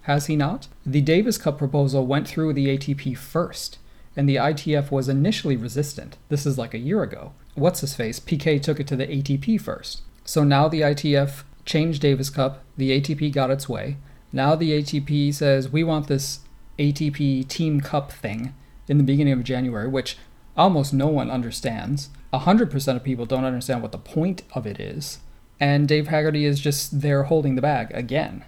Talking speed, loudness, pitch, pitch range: 185 wpm, -23 LUFS, 140 Hz, 130-150 Hz